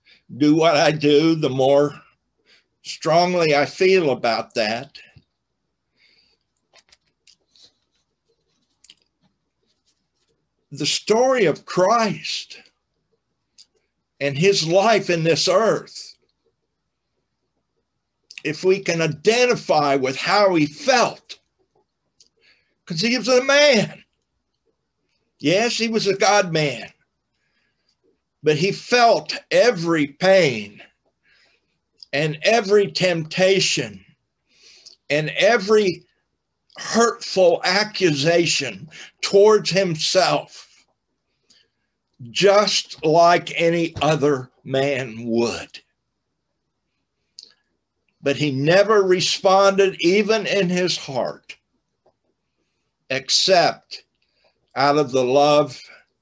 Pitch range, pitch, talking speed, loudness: 145-200 Hz, 170 Hz, 80 wpm, -18 LUFS